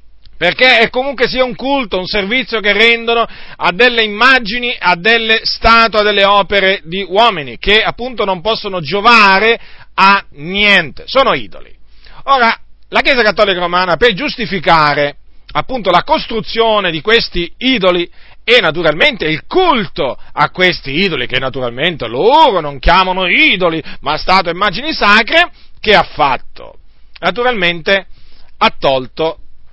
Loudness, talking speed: -11 LUFS, 135 wpm